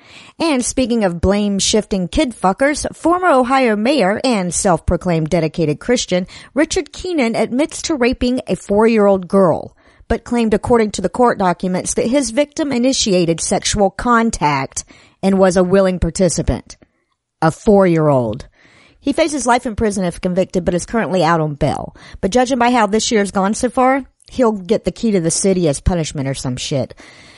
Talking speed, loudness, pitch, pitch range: 180 wpm, -16 LUFS, 205 Hz, 185-250 Hz